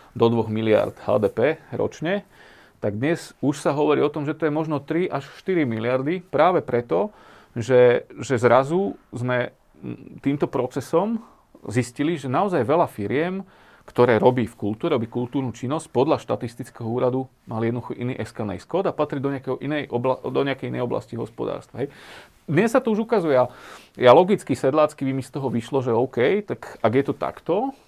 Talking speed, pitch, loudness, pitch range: 160 wpm, 130 Hz, -23 LUFS, 120-155 Hz